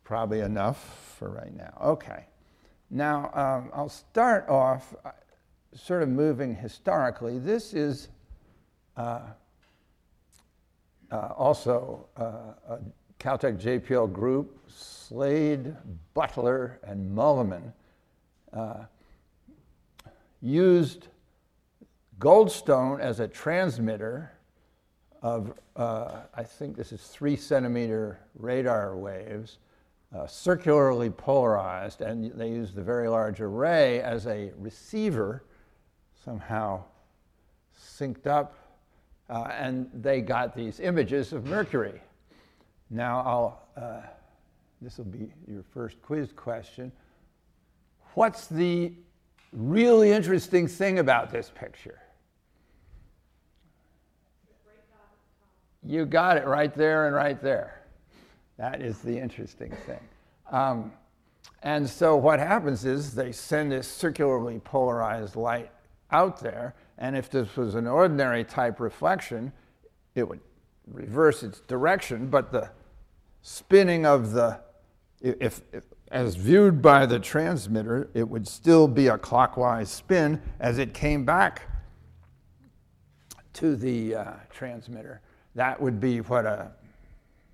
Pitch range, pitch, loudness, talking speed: 110-145 Hz, 125 Hz, -26 LUFS, 110 wpm